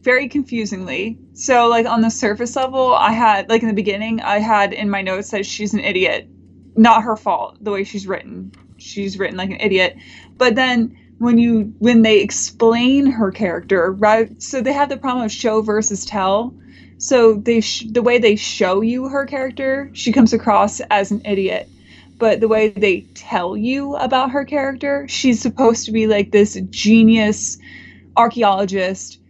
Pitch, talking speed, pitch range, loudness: 220 Hz, 180 wpm, 200-245 Hz, -16 LUFS